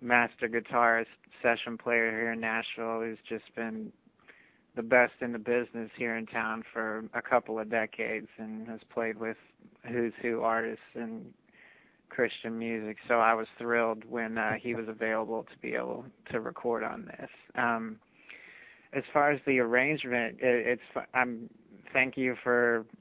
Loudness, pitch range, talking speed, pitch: -31 LUFS, 110-120 Hz, 160 wpm, 115 Hz